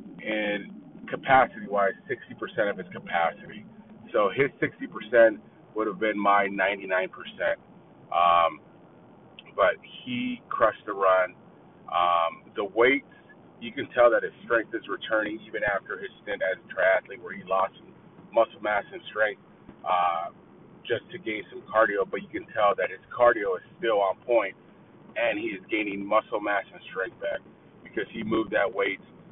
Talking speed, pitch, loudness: 160 wpm, 110 Hz, -26 LUFS